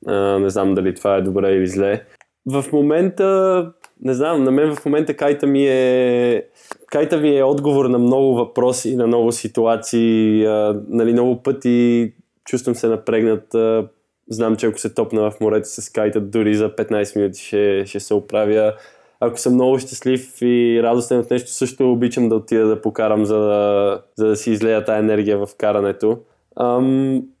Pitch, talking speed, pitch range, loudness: 115 Hz, 175 wpm, 105-130 Hz, -17 LUFS